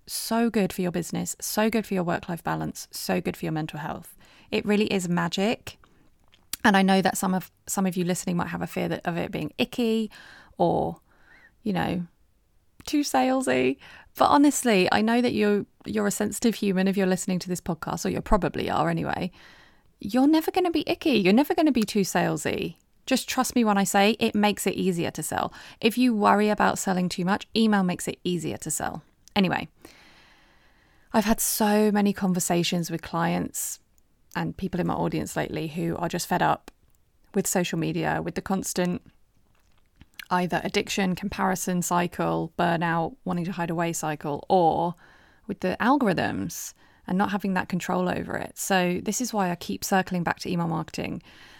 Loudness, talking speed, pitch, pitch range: -25 LUFS, 185 wpm, 190 Hz, 175-215 Hz